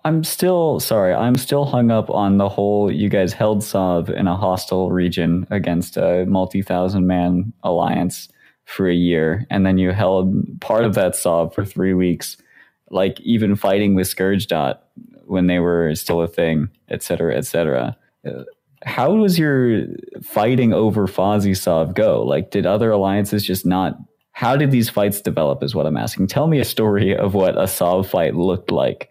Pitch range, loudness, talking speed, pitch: 90-110 Hz, -18 LUFS, 180 wpm, 100 Hz